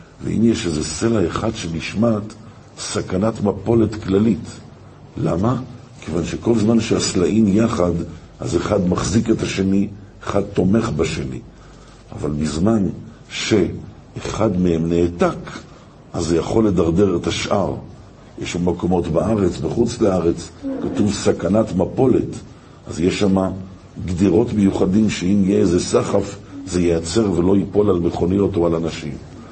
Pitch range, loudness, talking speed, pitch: 85-110 Hz, -19 LUFS, 125 wpm, 95 Hz